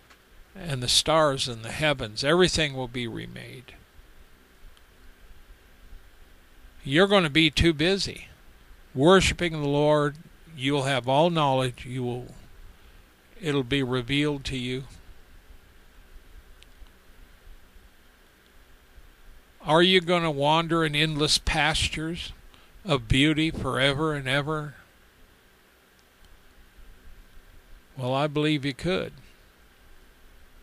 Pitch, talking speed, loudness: 120 Hz, 95 wpm, -24 LUFS